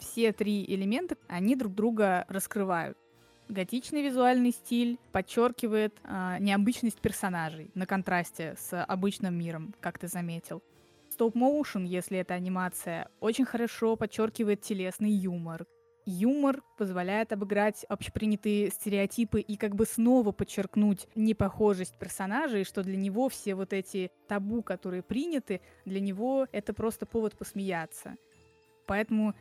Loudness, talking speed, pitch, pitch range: -31 LUFS, 120 wpm, 205 Hz, 185-225 Hz